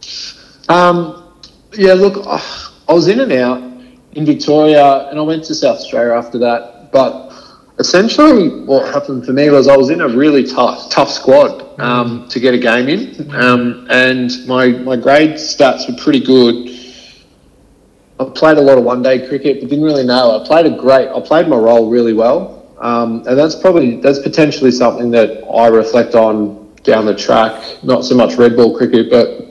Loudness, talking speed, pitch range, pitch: -11 LUFS, 185 wpm, 120-150 Hz, 130 Hz